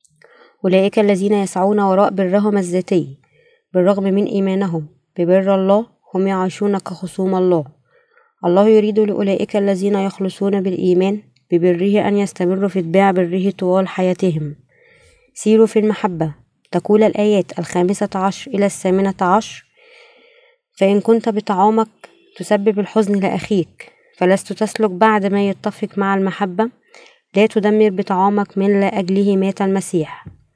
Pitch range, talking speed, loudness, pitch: 185-210 Hz, 120 wpm, -17 LUFS, 200 Hz